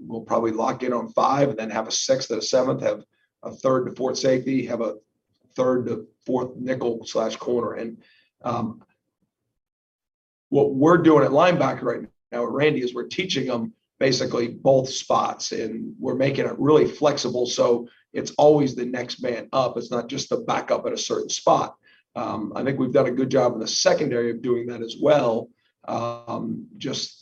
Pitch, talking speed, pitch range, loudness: 125 Hz, 185 wpm, 120-135 Hz, -23 LUFS